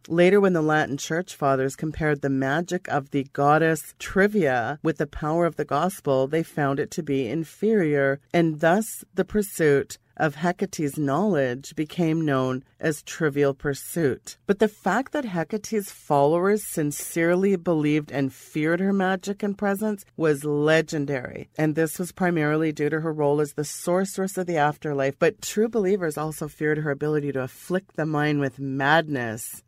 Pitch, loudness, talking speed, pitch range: 155 Hz, -24 LUFS, 160 wpm, 145-180 Hz